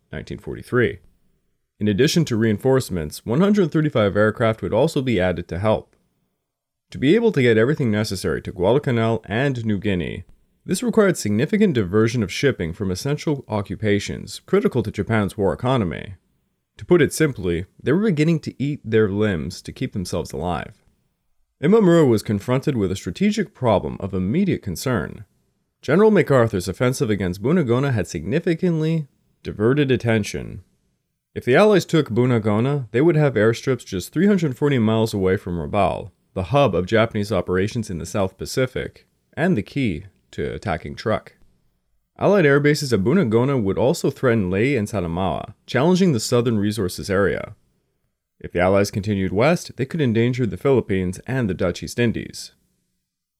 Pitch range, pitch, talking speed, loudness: 100-145 Hz, 115 Hz, 150 wpm, -20 LUFS